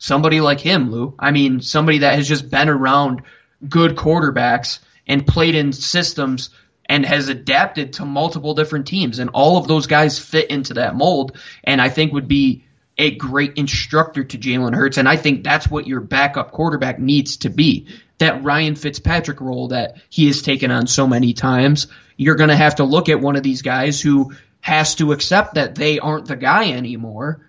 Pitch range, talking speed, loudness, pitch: 135-150 Hz, 195 wpm, -16 LUFS, 140 Hz